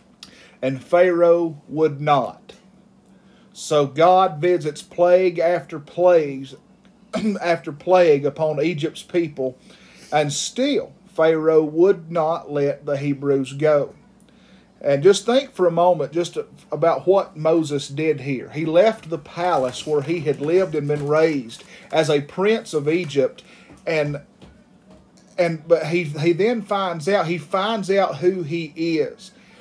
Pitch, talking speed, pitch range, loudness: 170 Hz, 135 wpm, 150-190 Hz, -20 LUFS